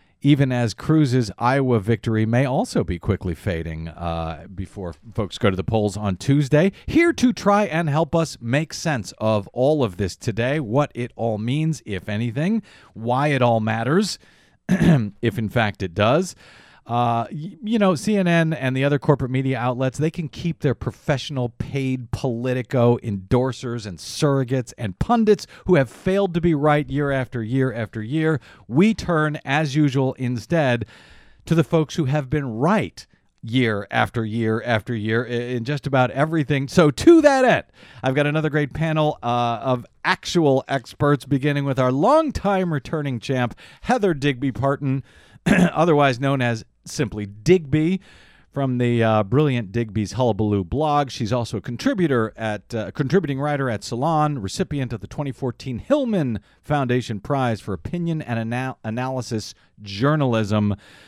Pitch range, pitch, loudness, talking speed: 115-155 Hz, 130 Hz, -21 LUFS, 155 wpm